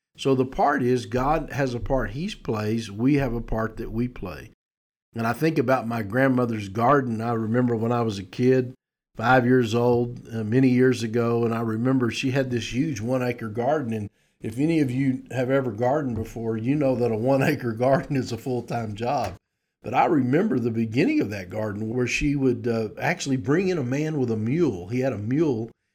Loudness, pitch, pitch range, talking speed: -24 LUFS, 125 Hz, 115-135 Hz, 215 wpm